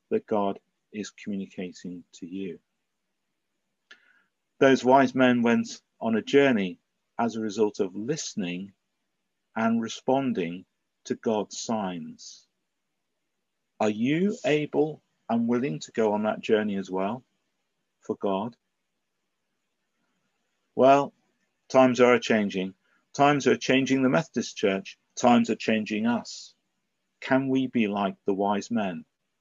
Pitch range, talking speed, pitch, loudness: 105-140 Hz, 120 wpm, 120 Hz, -25 LUFS